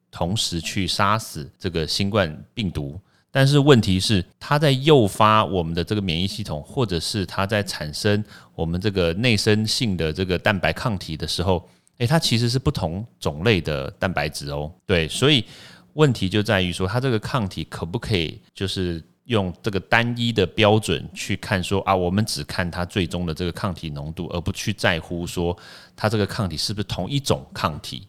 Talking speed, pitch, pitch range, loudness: 280 characters per minute, 100 Hz, 85-110 Hz, -22 LUFS